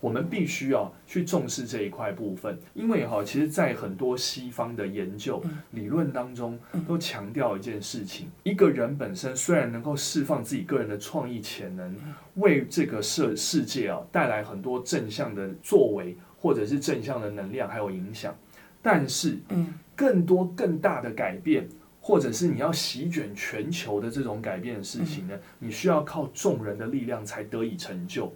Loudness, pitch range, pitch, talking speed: -28 LUFS, 115-170 Hz, 140 Hz, 270 characters per minute